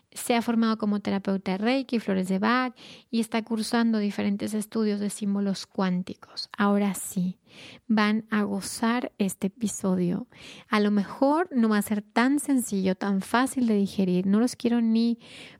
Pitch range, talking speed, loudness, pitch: 200-235 Hz, 160 wpm, -26 LUFS, 210 Hz